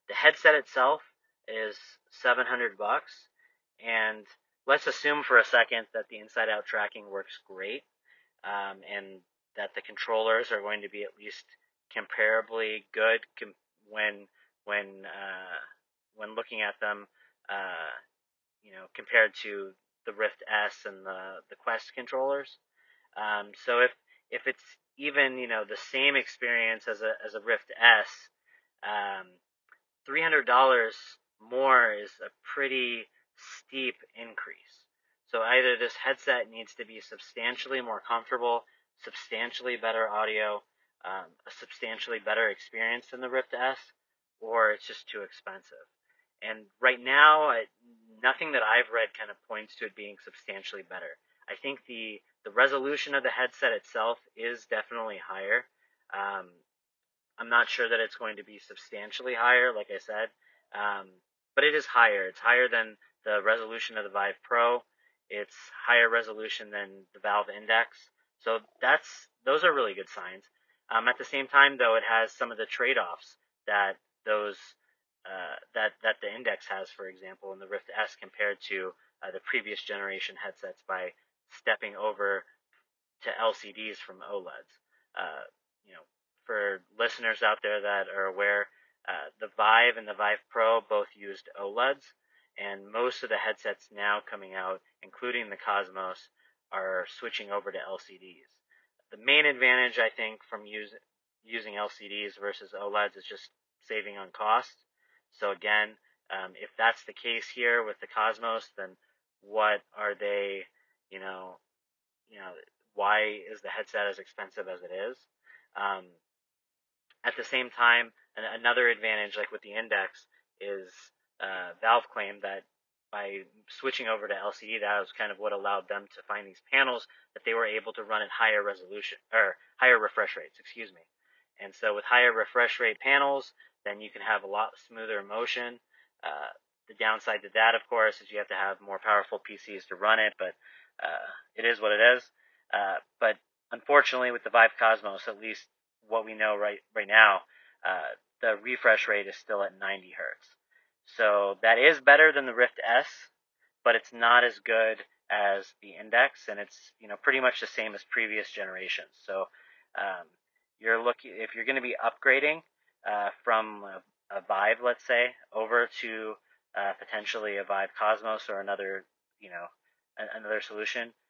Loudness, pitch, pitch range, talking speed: -28 LUFS, 115 Hz, 100-135 Hz, 160 wpm